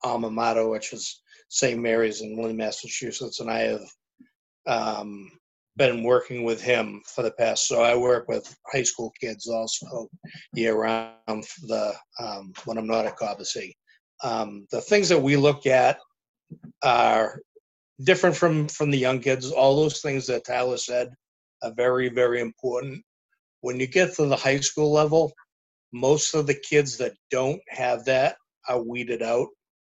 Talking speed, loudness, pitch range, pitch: 160 wpm, -24 LUFS, 115-145 Hz, 125 Hz